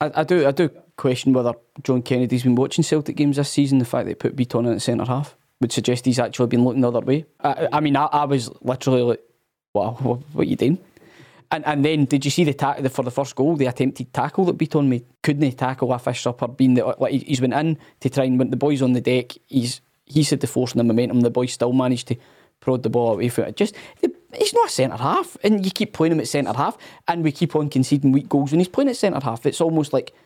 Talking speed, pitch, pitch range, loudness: 270 wpm, 135 Hz, 125-150 Hz, -21 LUFS